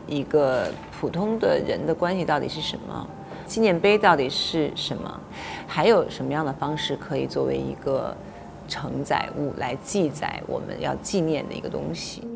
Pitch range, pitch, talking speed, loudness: 145-220 Hz, 175 Hz, 255 characters per minute, -25 LUFS